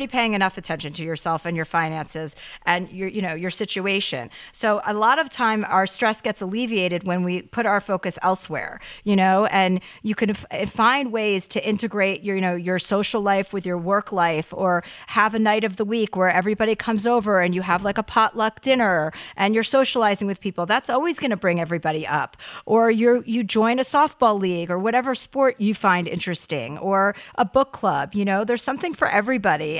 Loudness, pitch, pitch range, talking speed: -22 LUFS, 200 Hz, 180-225 Hz, 205 wpm